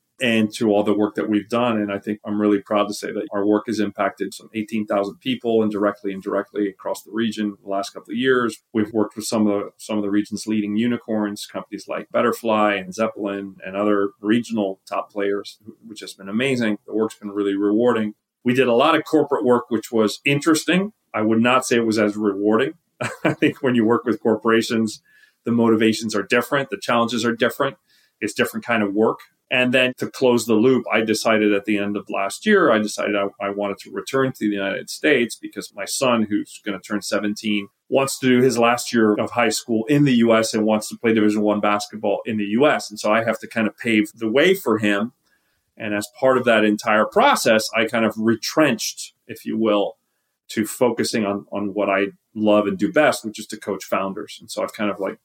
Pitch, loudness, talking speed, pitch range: 110 Hz, -20 LUFS, 225 wpm, 105-120 Hz